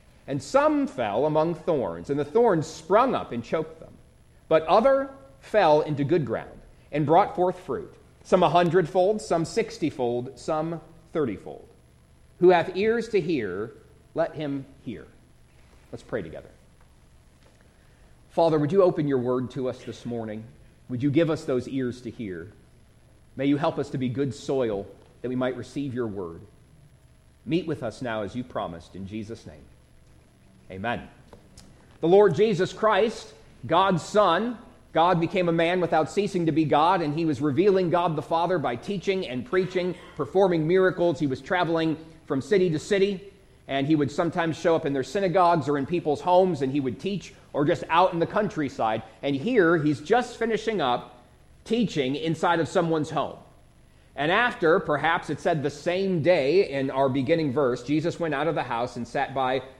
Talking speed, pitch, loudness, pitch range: 175 wpm, 155 Hz, -25 LUFS, 130-180 Hz